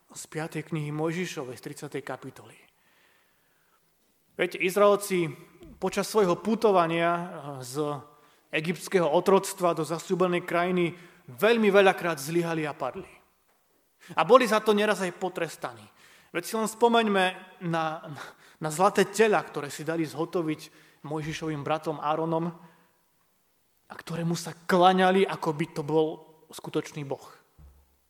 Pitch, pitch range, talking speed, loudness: 165 Hz, 155-185 Hz, 115 wpm, -27 LUFS